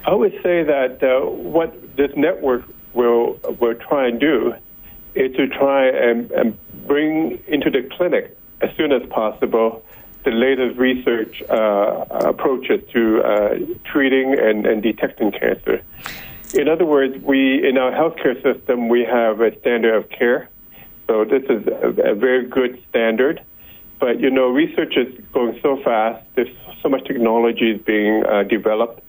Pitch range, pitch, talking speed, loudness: 120-150 Hz, 130 Hz, 155 wpm, -18 LUFS